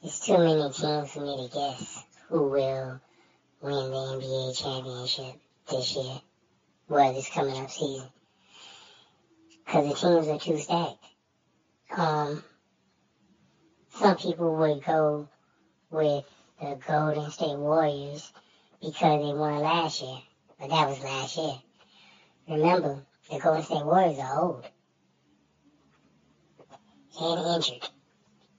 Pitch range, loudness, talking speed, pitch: 135-160 Hz, -28 LUFS, 120 wpm, 150 Hz